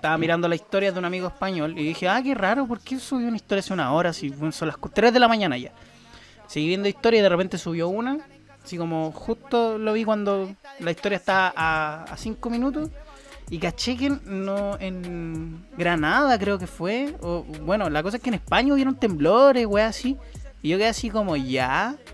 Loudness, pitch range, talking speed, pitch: -24 LUFS, 170-235 Hz, 210 wpm, 195 Hz